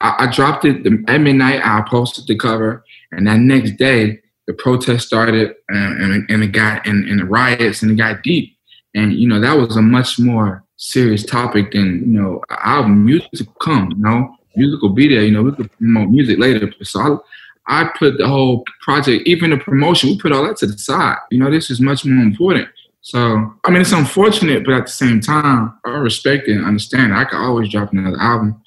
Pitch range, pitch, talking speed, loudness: 105-130 Hz, 115 Hz, 220 wpm, -14 LUFS